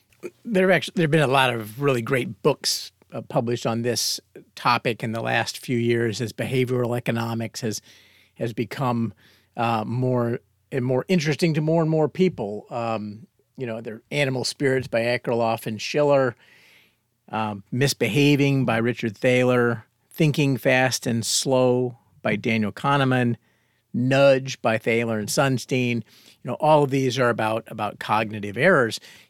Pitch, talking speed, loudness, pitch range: 120 Hz, 150 wpm, -23 LUFS, 115-135 Hz